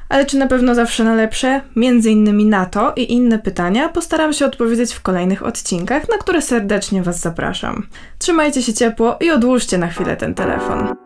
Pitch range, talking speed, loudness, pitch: 210-275 Hz, 185 wpm, -16 LUFS, 235 Hz